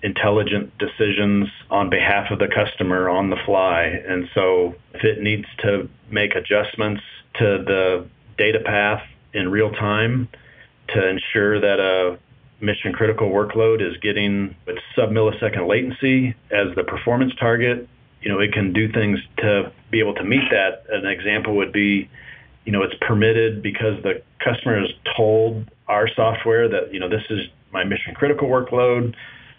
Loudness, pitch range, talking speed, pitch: -20 LUFS, 100-115 Hz, 155 wpm, 105 Hz